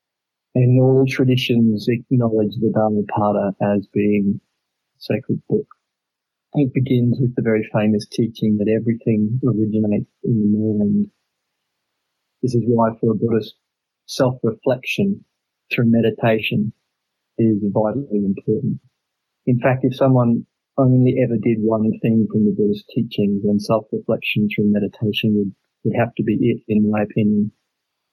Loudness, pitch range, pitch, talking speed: -19 LUFS, 105-125 Hz, 110 Hz, 130 wpm